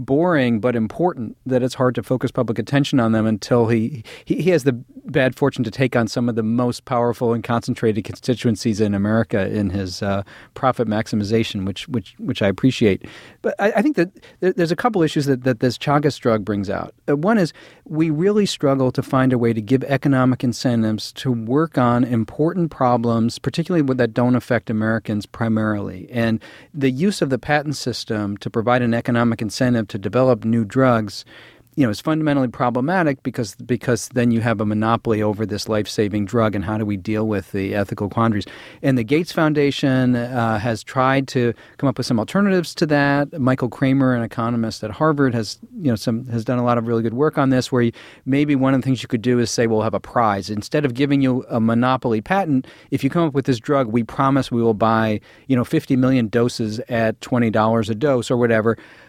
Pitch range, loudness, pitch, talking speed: 115-135 Hz, -20 LUFS, 120 Hz, 210 wpm